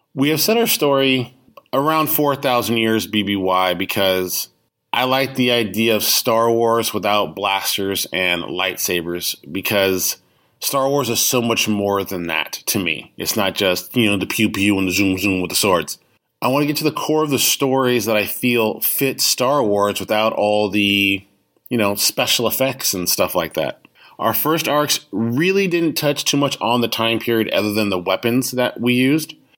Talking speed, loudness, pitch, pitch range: 190 wpm, -18 LUFS, 115 Hz, 100-135 Hz